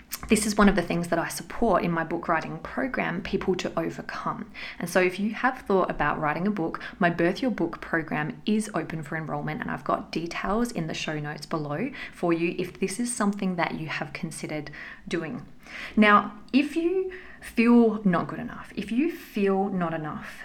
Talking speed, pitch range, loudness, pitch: 200 wpm, 165-220 Hz, -27 LUFS, 190 Hz